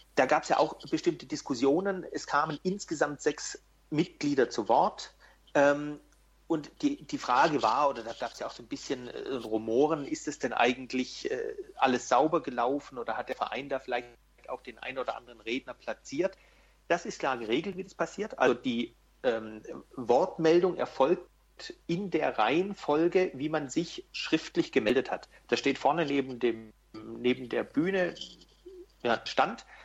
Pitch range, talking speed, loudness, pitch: 130-190 Hz, 165 wpm, -30 LUFS, 155 Hz